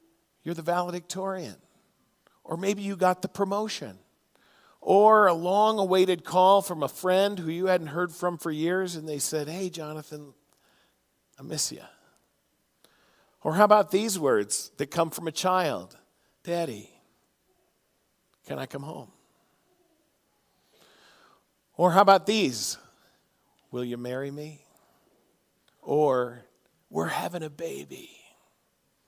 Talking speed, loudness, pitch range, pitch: 125 wpm, -26 LUFS, 155-190 Hz, 175 Hz